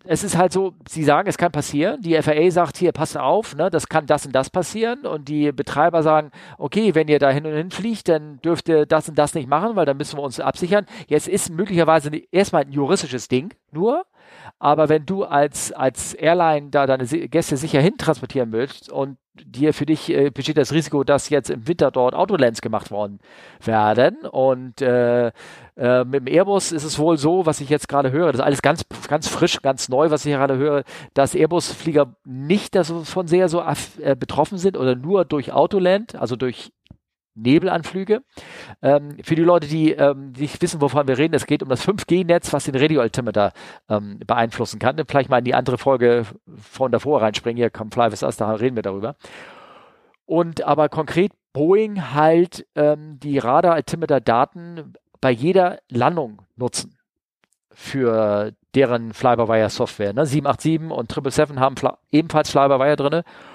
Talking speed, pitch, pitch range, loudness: 180 wpm, 150 Hz, 130-165 Hz, -19 LUFS